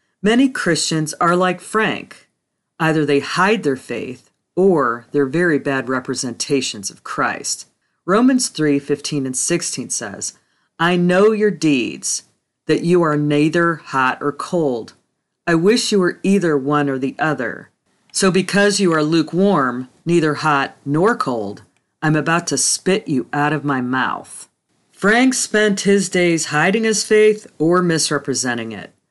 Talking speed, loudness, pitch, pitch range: 145 wpm, -17 LUFS, 160 Hz, 140-190 Hz